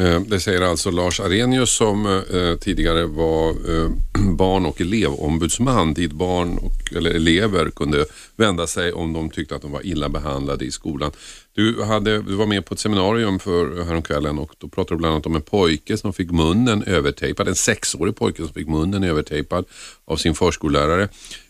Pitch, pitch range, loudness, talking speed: 90 Hz, 80-100 Hz, -20 LUFS, 180 wpm